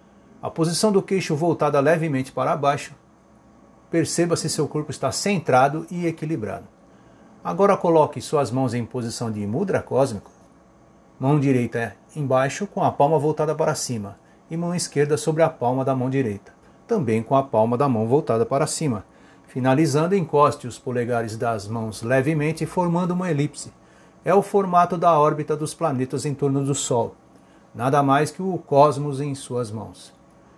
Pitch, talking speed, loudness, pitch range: 145 Hz, 160 wpm, -22 LUFS, 125-160 Hz